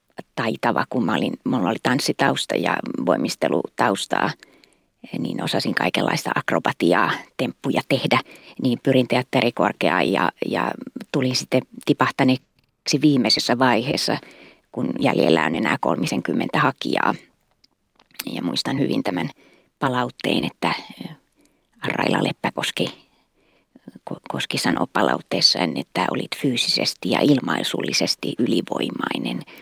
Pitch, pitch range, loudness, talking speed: 130 Hz, 130-145 Hz, -21 LUFS, 95 wpm